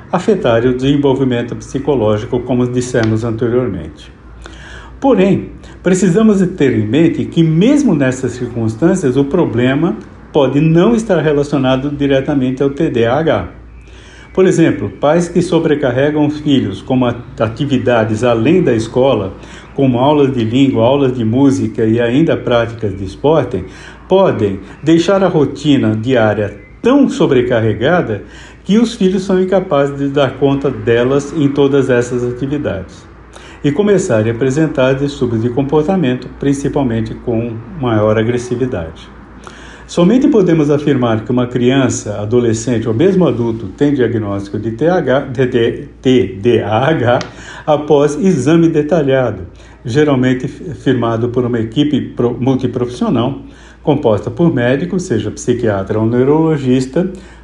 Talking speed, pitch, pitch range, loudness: 120 wpm, 130 Hz, 115-150 Hz, -13 LUFS